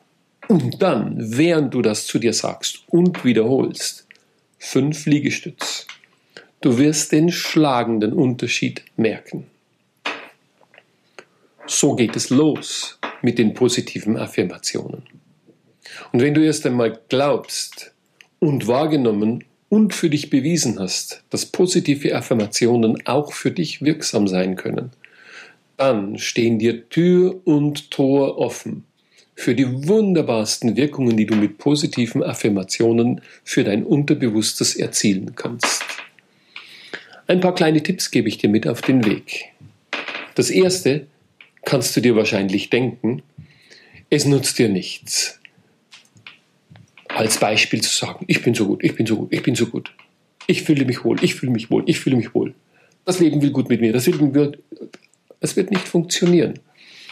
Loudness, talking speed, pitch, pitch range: -19 LUFS, 140 wpm, 140 Hz, 115-160 Hz